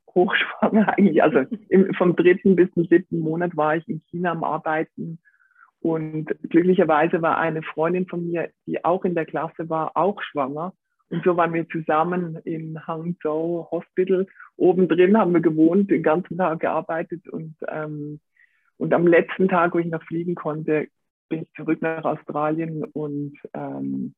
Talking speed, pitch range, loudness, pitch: 165 wpm, 155-180 Hz, -22 LUFS, 165 Hz